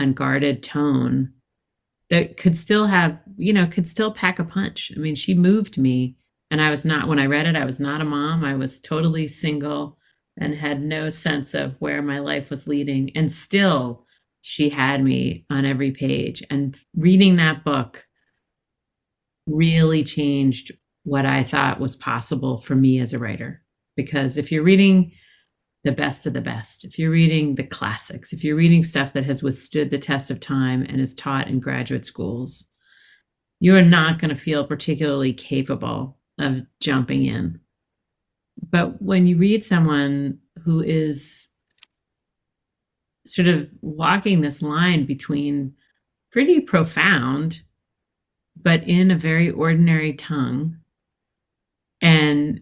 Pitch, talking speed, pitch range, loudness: 145 Hz, 150 wpm, 135-165 Hz, -20 LUFS